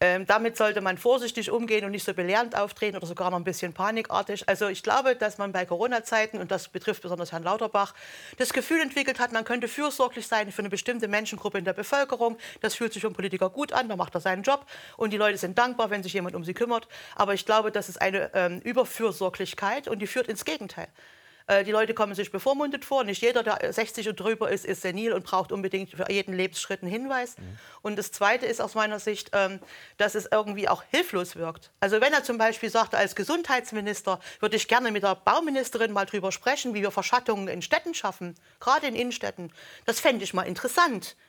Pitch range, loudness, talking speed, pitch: 190-235 Hz, -27 LUFS, 215 wpm, 210 Hz